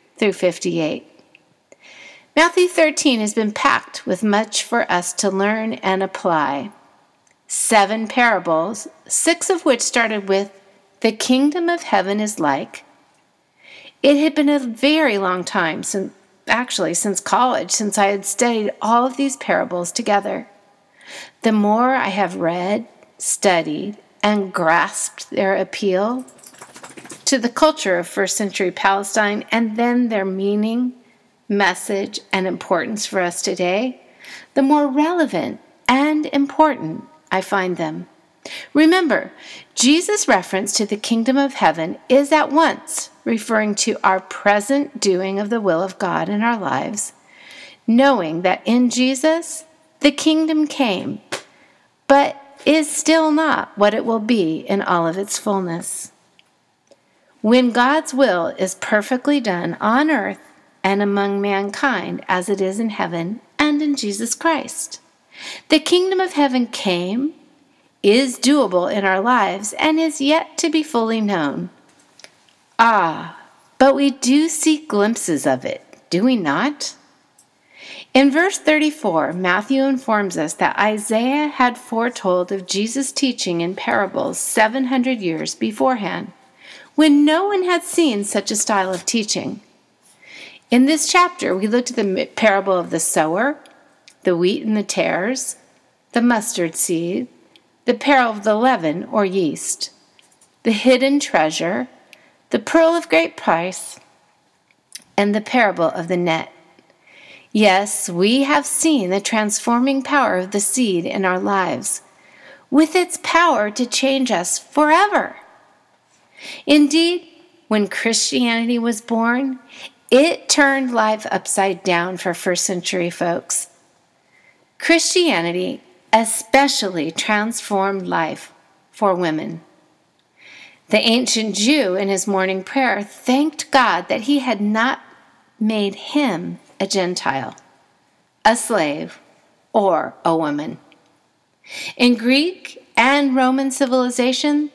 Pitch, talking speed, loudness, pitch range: 230 Hz, 130 wpm, -18 LUFS, 195-280 Hz